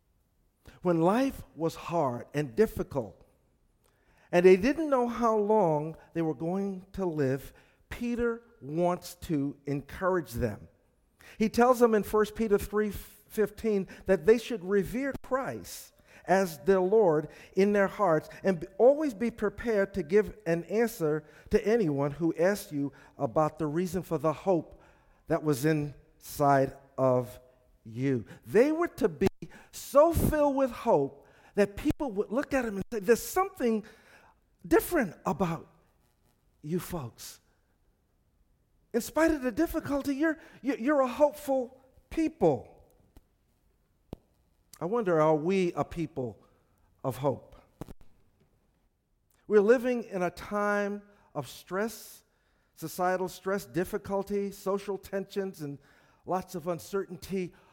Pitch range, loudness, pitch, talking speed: 150-225 Hz, -29 LUFS, 190 Hz, 125 wpm